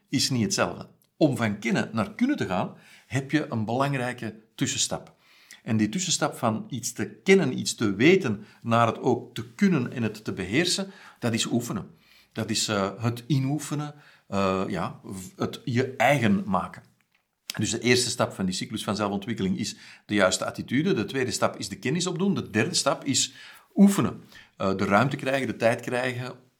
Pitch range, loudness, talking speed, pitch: 110-145 Hz, -26 LUFS, 180 wpm, 120 Hz